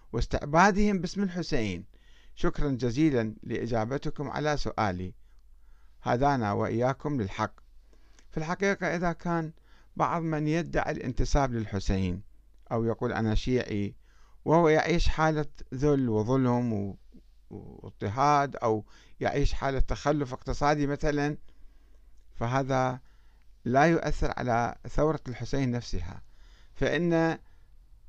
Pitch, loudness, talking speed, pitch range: 130 Hz, -29 LUFS, 95 wpm, 110-150 Hz